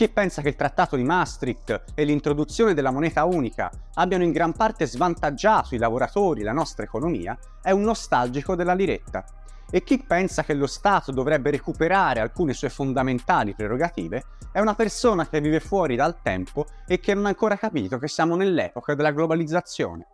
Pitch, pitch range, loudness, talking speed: 160 Hz, 145-190 Hz, -23 LUFS, 175 wpm